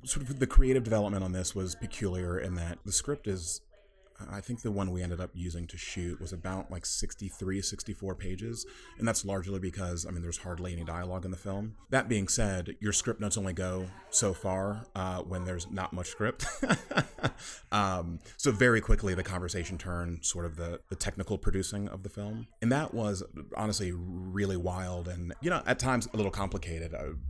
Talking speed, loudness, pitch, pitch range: 200 wpm, -33 LUFS, 95 Hz, 90-105 Hz